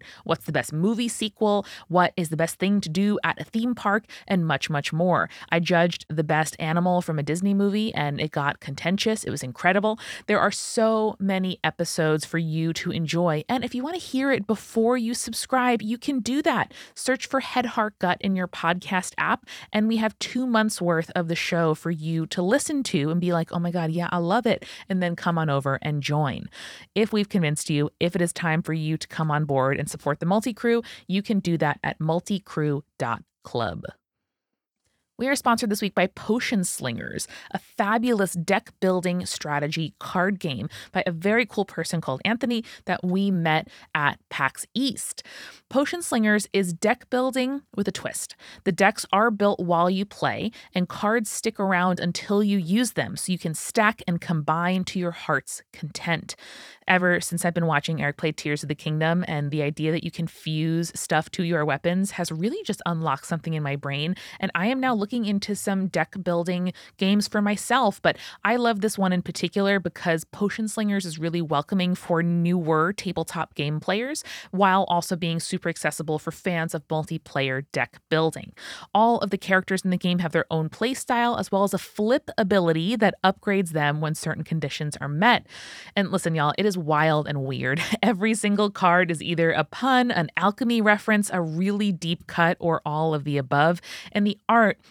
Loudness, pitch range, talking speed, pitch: -24 LUFS, 160-210 Hz, 195 wpm, 180 Hz